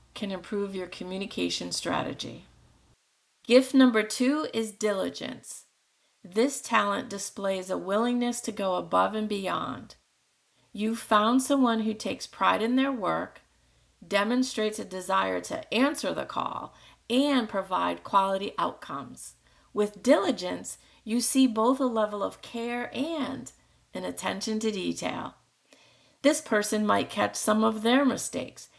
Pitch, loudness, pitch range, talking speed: 220 Hz, -27 LUFS, 200-250 Hz, 130 wpm